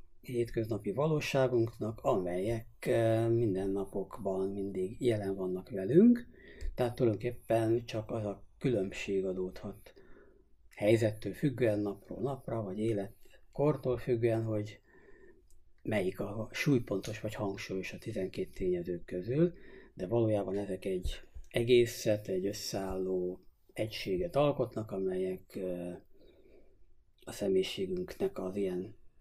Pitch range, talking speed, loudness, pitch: 95-120 Hz, 95 wpm, -34 LUFS, 110 Hz